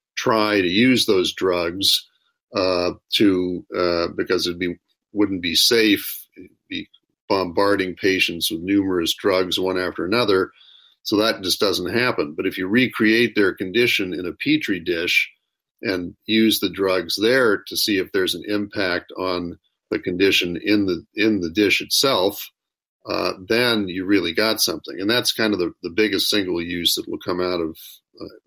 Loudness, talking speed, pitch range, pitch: -20 LUFS, 165 wpm, 90-120 Hz, 100 Hz